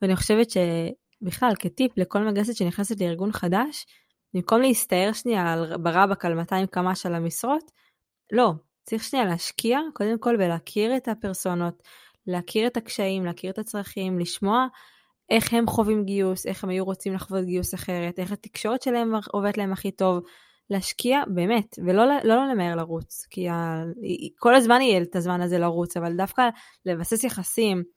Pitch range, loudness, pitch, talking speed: 180-230 Hz, -24 LUFS, 195 Hz, 160 wpm